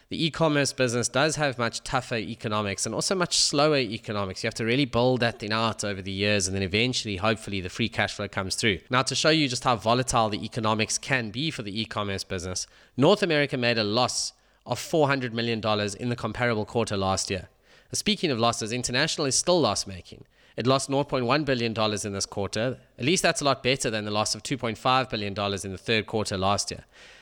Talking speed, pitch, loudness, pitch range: 215 wpm, 115 Hz, -26 LUFS, 105-130 Hz